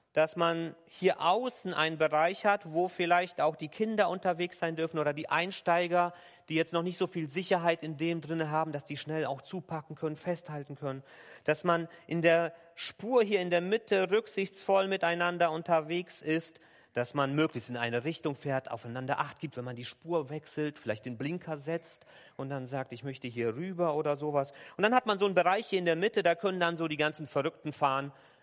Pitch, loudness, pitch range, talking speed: 165 Hz, -32 LUFS, 150-175 Hz, 205 wpm